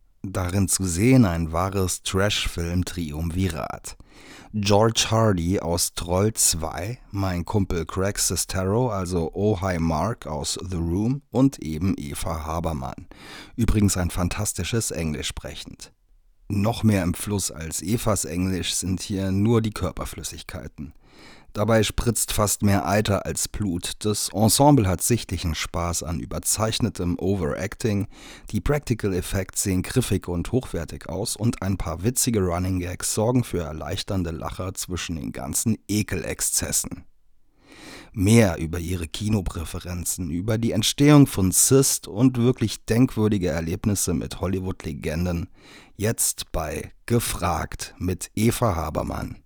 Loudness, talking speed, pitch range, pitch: -23 LUFS, 125 wpm, 85-110 Hz, 95 Hz